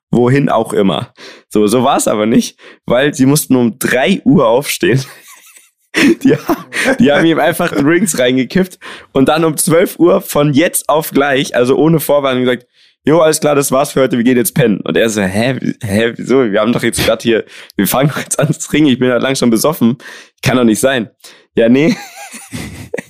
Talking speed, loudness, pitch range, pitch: 200 wpm, -12 LUFS, 120-145 Hz, 130 Hz